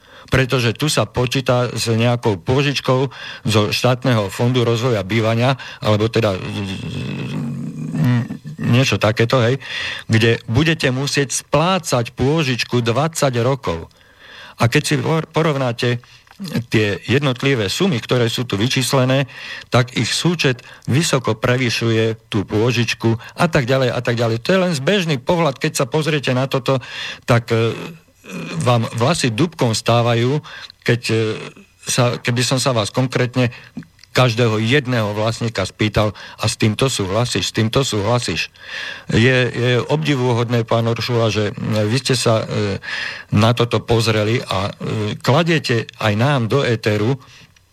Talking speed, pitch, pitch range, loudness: 130 wpm, 120 Hz, 110-135 Hz, -18 LUFS